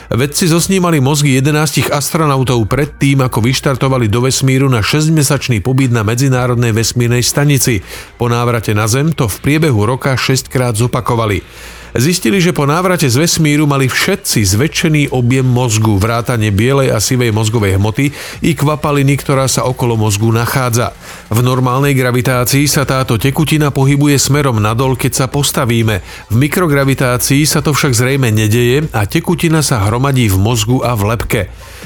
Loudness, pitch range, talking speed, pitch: -12 LUFS, 120-145 Hz, 150 wpm, 130 Hz